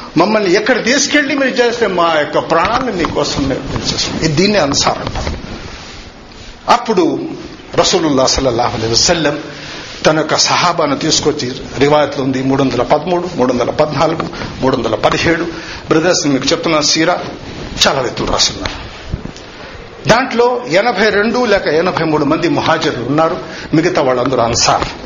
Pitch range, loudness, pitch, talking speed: 135-180 Hz, -13 LUFS, 155 Hz, 115 wpm